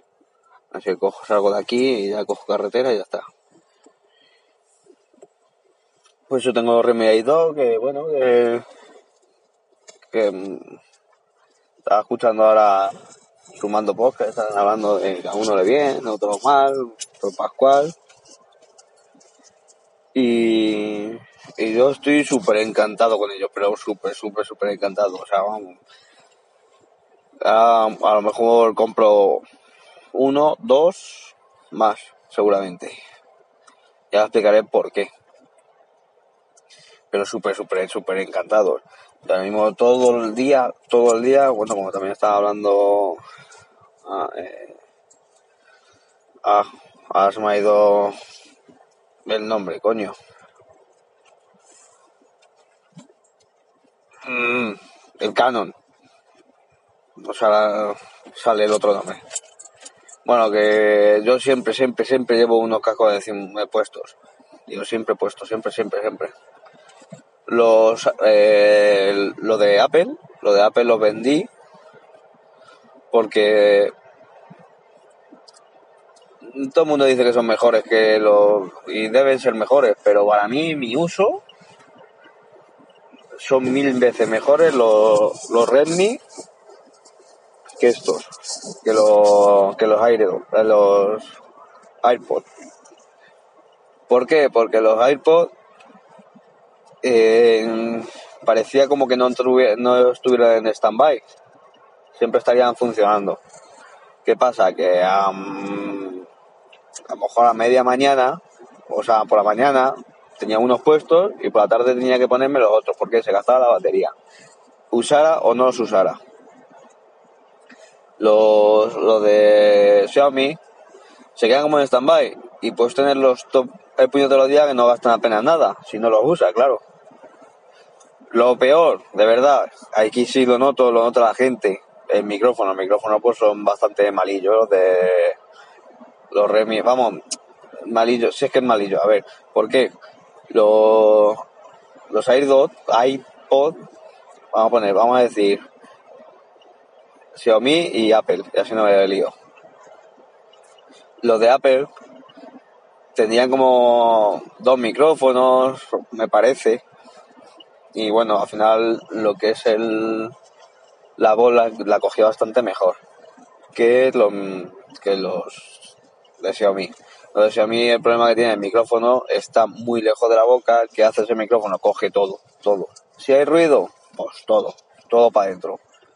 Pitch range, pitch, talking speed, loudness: 105-135 Hz, 115 Hz, 125 wpm, -17 LUFS